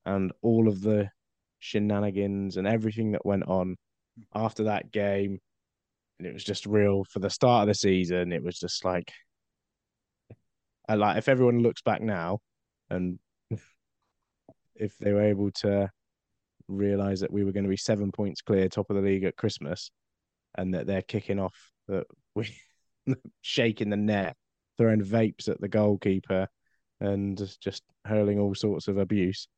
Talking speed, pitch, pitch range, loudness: 160 wpm, 100 Hz, 95-105 Hz, -28 LUFS